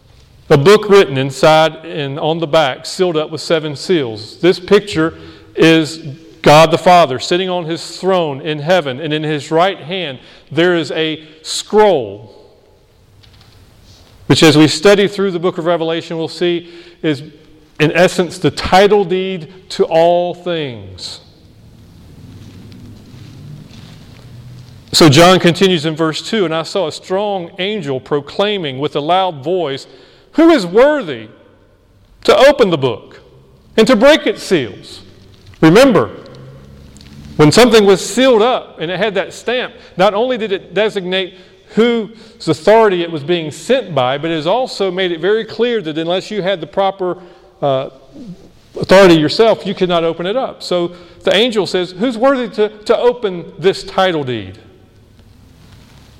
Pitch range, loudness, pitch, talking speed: 150-195 Hz, -13 LUFS, 170 Hz, 150 wpm